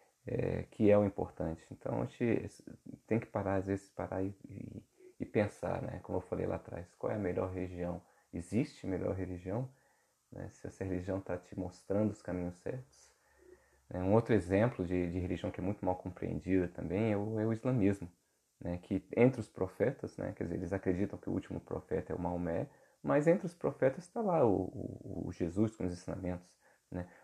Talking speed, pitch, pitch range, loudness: 200 wpm, 95 Hz, 90-110 Hz, -36 LUFS